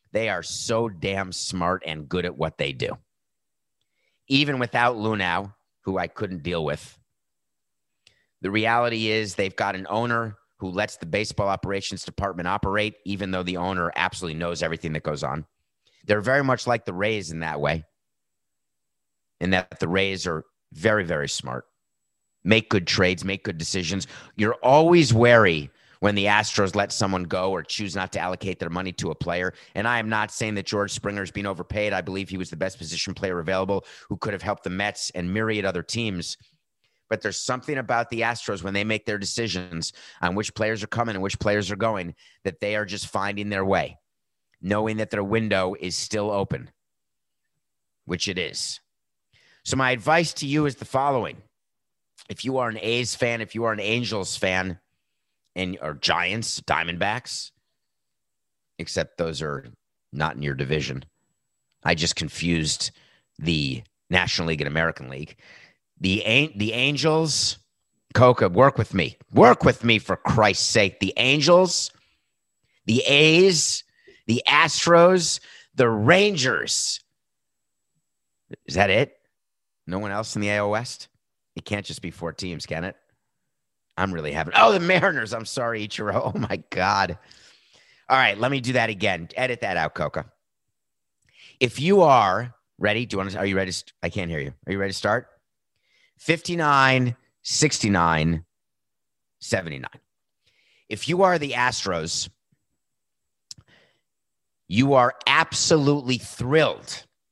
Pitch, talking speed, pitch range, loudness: 105 Hz, 160 wpm, 95-120 Hz, -23 LUFS